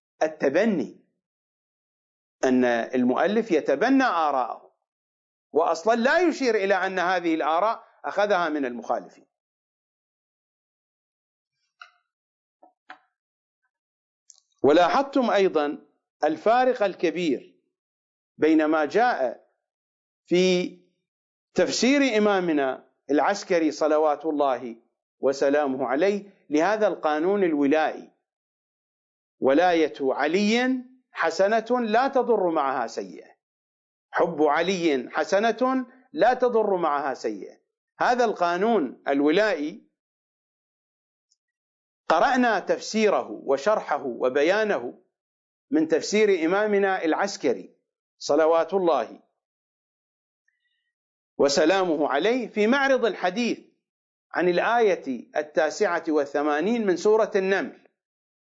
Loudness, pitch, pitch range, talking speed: -23 LUFS, 195 Hz, 155-240 Hz, 75 wpm